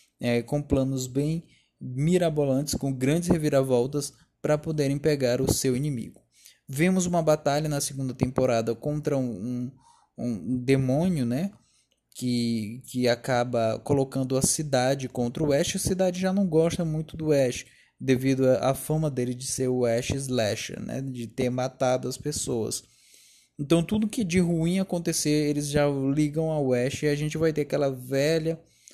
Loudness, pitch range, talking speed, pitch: -26 LUFS, 130-155 Hz, 155 wpm, 140 Hz